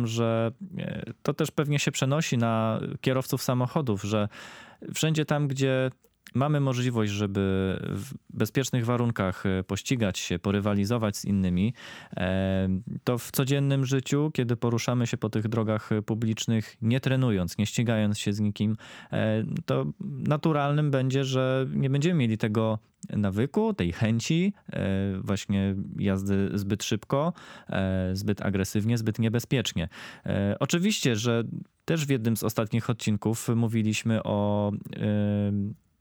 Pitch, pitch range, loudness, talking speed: 115 Hz, 105-135 Hz, -27 LUFS, 120 wpm